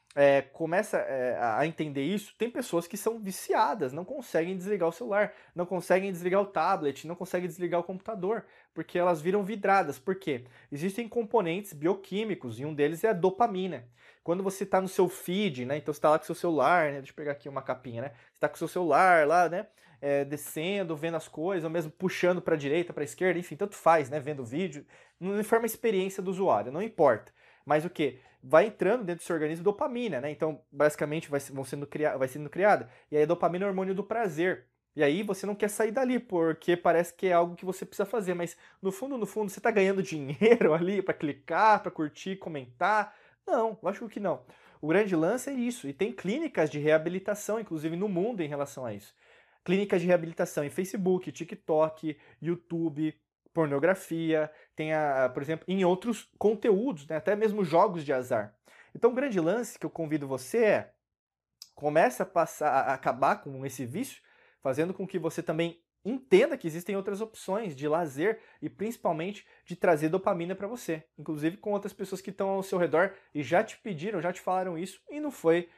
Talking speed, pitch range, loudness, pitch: 205 wpm, 155-200 Hz, -29 LUFS, 175 Hz